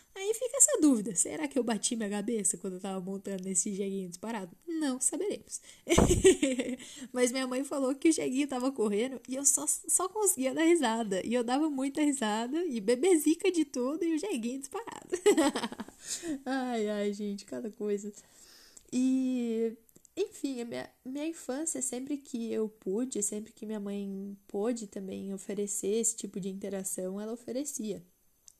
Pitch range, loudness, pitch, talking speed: 210-290 Hz, -31 LUFS, 245 Hz, 160 wpm